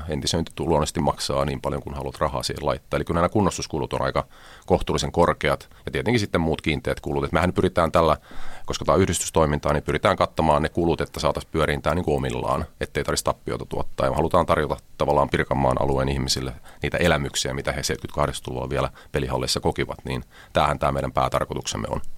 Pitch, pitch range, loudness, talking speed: 75 Hz, 70-85 Hz, -24 LUFS, 185 wpm